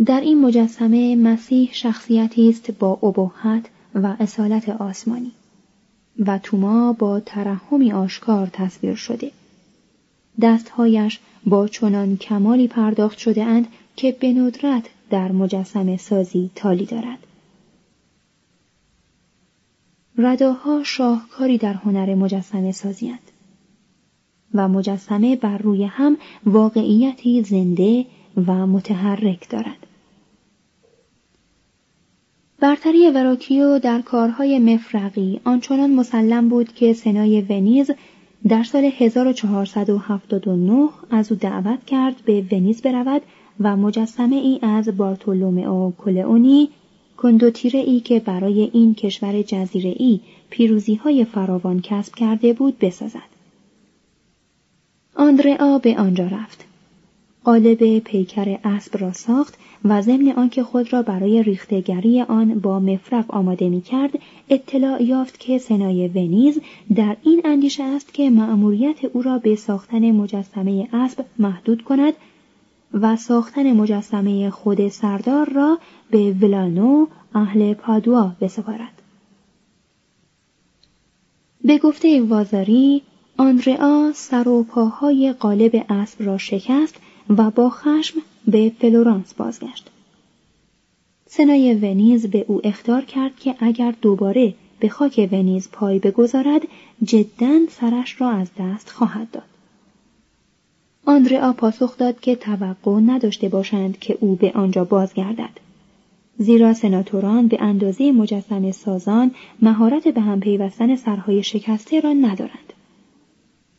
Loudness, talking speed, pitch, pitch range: -18 LUFS, 110 wpm, 220 Hz, 200-250 Hz